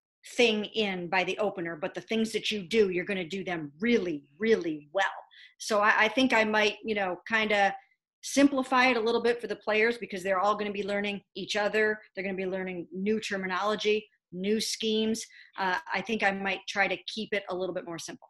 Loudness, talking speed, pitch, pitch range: -28 LUFS, 225 wpm, 205 Hz, 190-220 Hz